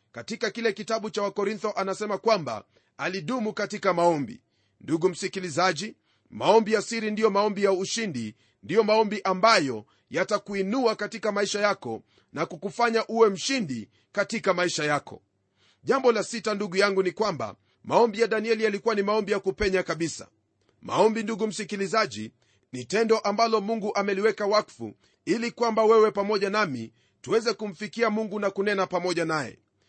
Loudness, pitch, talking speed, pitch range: -26 LUFS, 205 Hz, 140 wpm, 175-220 Hz